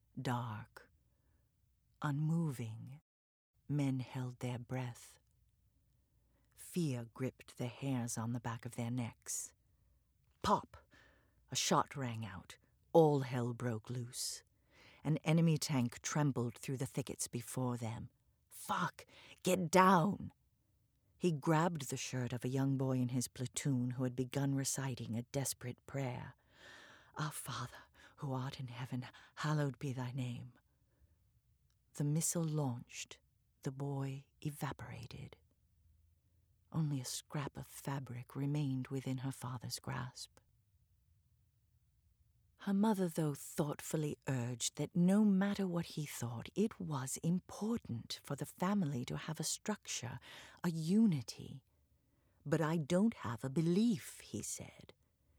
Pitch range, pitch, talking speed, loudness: 120-150 Hz, 130 Hz, 120 wpm, -38 LUFS